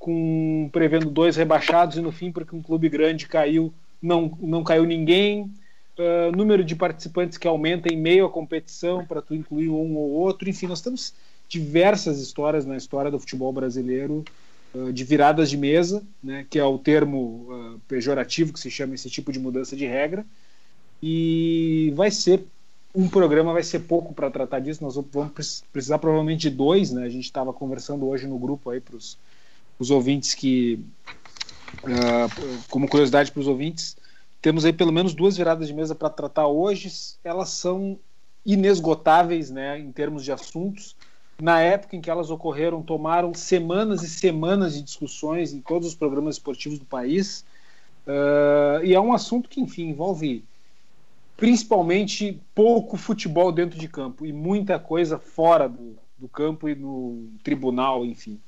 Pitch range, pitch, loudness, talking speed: 140-175 Hz, 160 Hz, -23 LUFS, 165 wpm